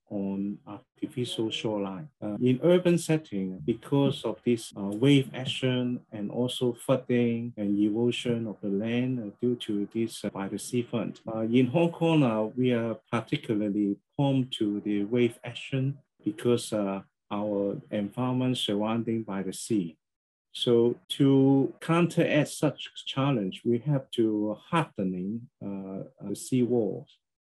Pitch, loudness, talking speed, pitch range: 120 Hz, -28 LUFS, 140 wpm, 105-130 Hz